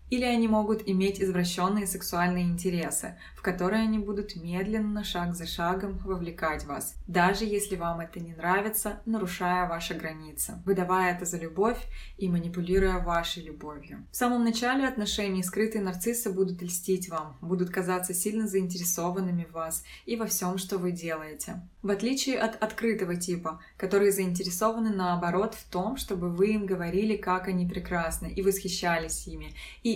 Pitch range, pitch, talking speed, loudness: 175-210 Hz, 185 Hz, 150 wpm, -29 LUFS